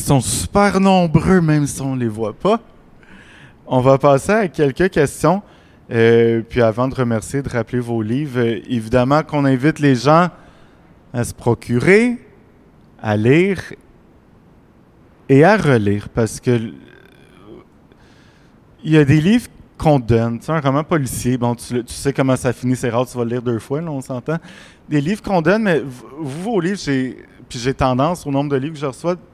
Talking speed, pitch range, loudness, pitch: 185 wpm, 120-160 Hz, -17 LUFS, 135 Hz